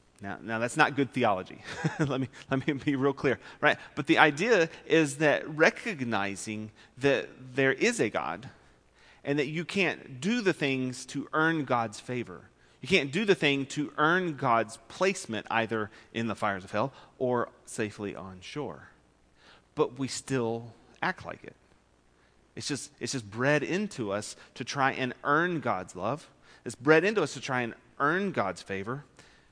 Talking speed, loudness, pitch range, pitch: 170 wpm, -29 LUFS, 110-145 Hz, 130 Hz